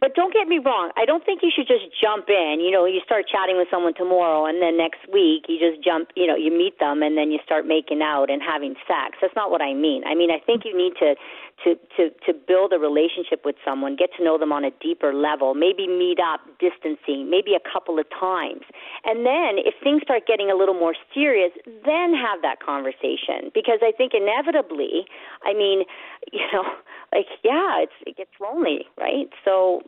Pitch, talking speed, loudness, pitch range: 180 Hz, 220 wpm, -21 LUFS, 160-235 Hz